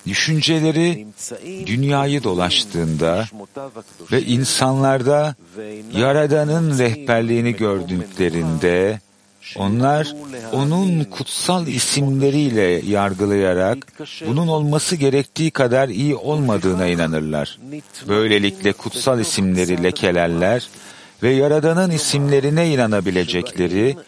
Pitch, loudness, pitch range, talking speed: 125 Hz, -18 LUFS, 100-145 Hz, 70 wpm